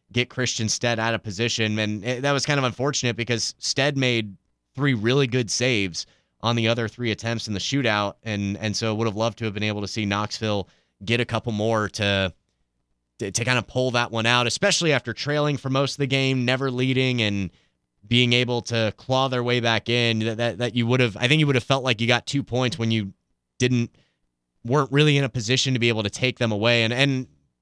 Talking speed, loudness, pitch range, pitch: 230 wpm, -23 LUFS, 110-130 Hz, 120 Hz